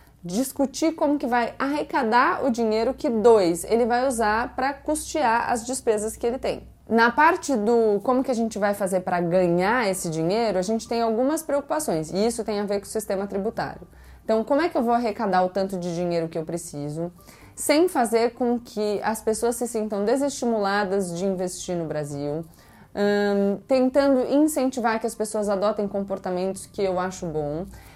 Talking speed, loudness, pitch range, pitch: 180 wpm, -24 LUFS, 190-245 Hz, 220 Hz